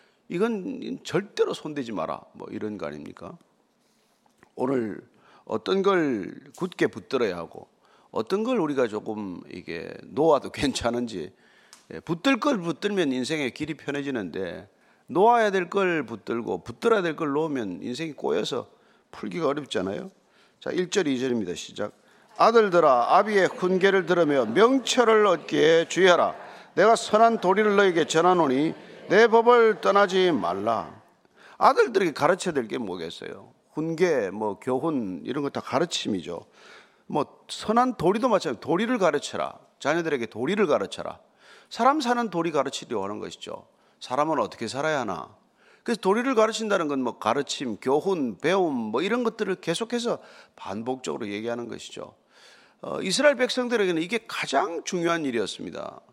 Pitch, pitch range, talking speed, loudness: 190 Hz, 155-230 Hz, 320 characters per minute, -24 LUFS